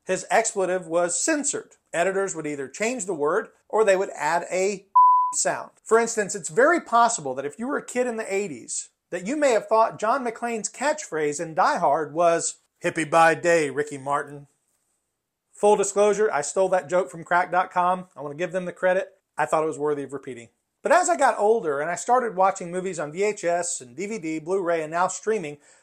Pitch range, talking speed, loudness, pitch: 160-215 Hz, 200 wpm, -23 LUFS, 185 Hz